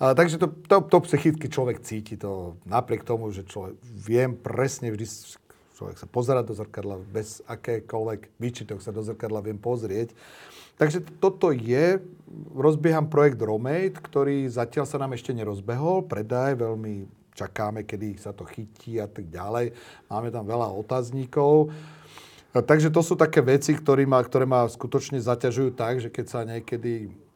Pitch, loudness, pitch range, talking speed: 120 Hz, -25 LUFS, 110-145 Hz, 150 wpm